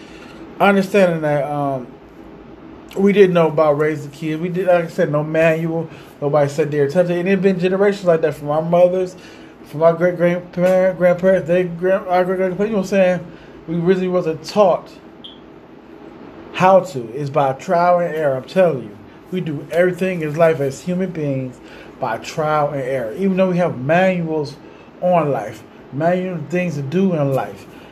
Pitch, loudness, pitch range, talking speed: 175 Hz, -17 LUFS, 150-185 Hz, 180 wpm